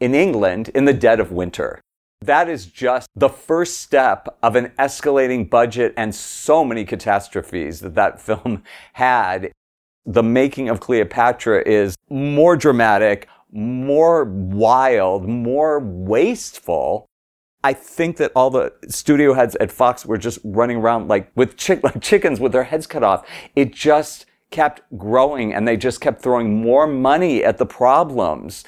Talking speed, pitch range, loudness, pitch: 155 wpm, 110-140 Hz, -17 LUFS, 125 Hz